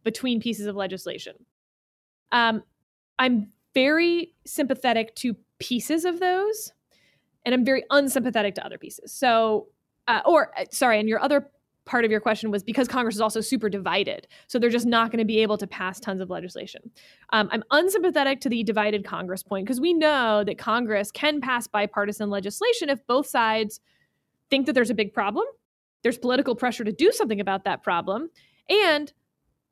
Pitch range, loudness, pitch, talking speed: 215-275 Hz, -24 LUFS, 235 Hz, 175 wpm